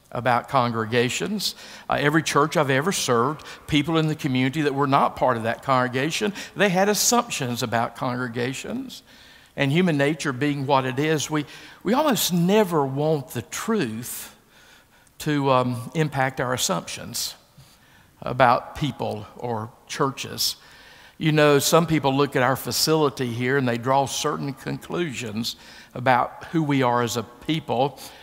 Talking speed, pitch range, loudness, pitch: 145 wpm, 125-160 Hz, -23 LUFS, 140 Hz